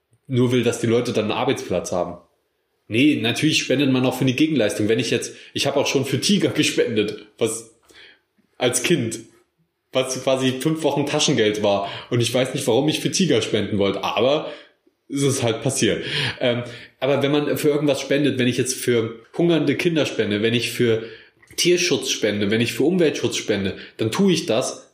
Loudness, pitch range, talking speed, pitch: -20 LUFS, 115-150 Hz, 190 wpm, 130 Hz